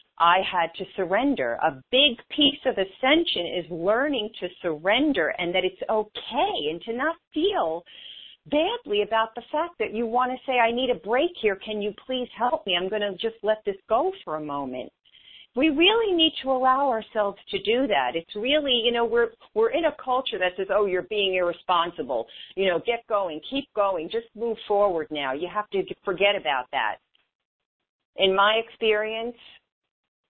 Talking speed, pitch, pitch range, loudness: 185 wpm, 215 Hz, 190-260 Hz, -24 LUFS